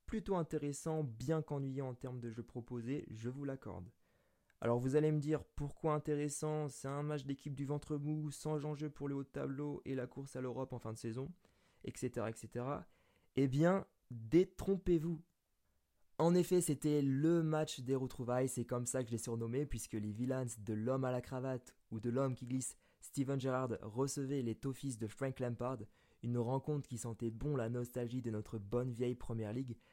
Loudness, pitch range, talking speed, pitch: -40 LUFS, 120-145 Hz, 195 wpm, 130 Hz